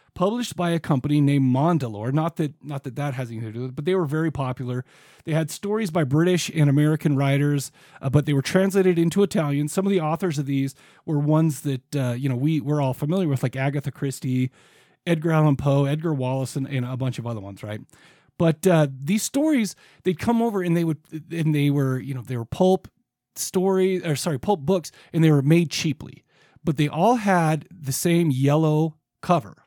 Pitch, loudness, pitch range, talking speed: 150 Hz, -23 LUFS, 135-170 Hz, 215 wpm